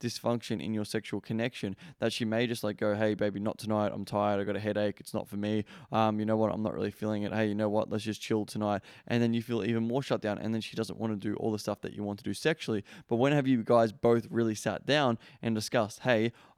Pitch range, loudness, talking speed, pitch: 105-115 Hz, -31 LUFS, 280 wpm, 110 Hz